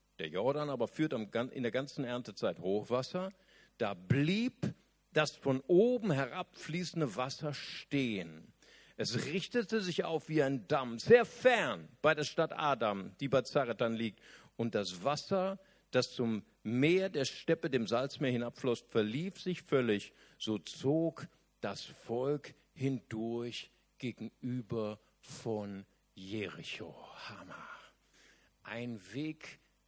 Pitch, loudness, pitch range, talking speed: 135 Hz, -35 LUFS, 115-165 Hz, 120 wpm